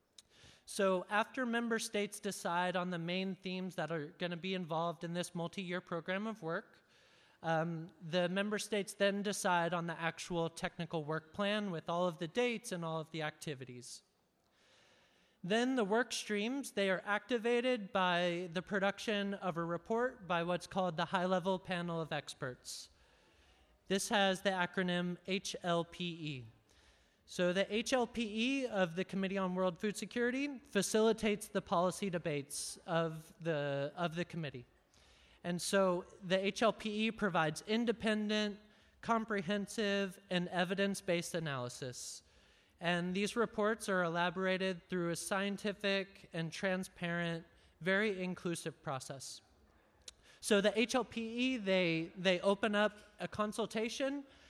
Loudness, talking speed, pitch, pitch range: -37 LUFS, 135 wpm, 185 Hz, 170-210 Hz